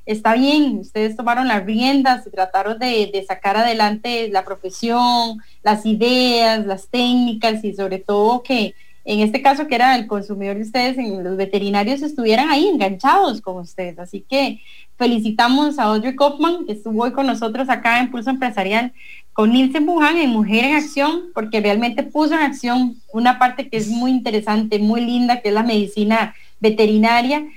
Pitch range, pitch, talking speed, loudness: 215-255 Hz, 235 Hz, 170 wpm, -17 LUFS